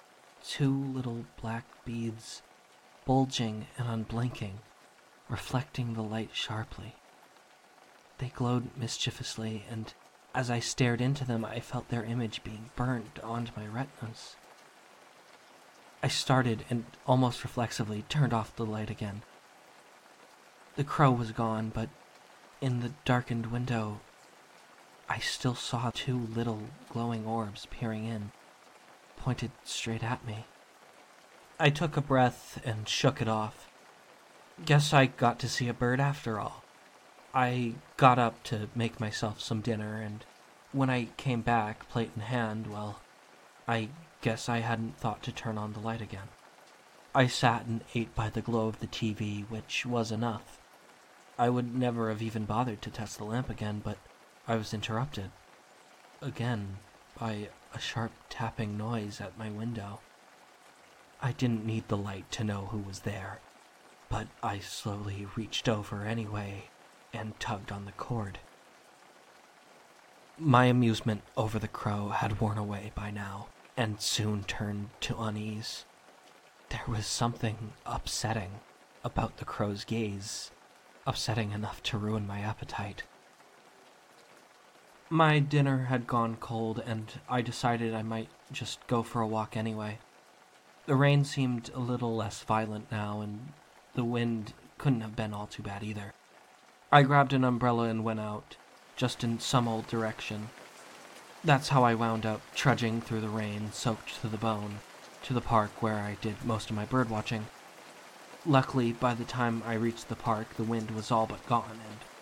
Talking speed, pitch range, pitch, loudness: 150 wpm, 110-125 Hz, 115 Hz, -32 LUFS